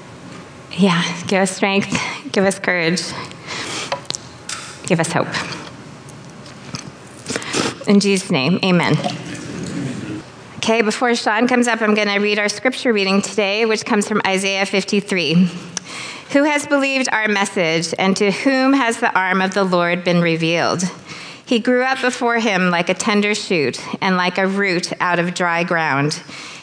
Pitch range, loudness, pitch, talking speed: 175-220 Hz, -17 LUFS, 195 Hz, 145 wpm